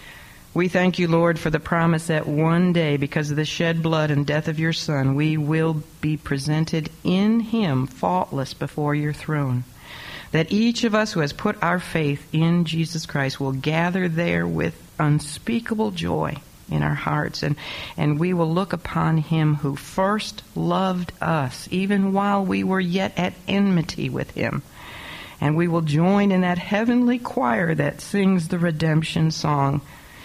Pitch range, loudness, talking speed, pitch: 150-180 Hz, -22 LUFS, 165 wpm, 160 Hz